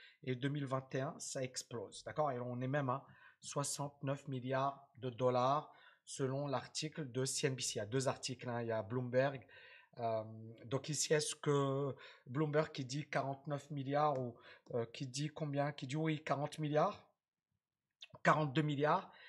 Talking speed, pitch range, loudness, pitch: 155 wpm, 130-150 Hz, -39 LUFS, 140 Hz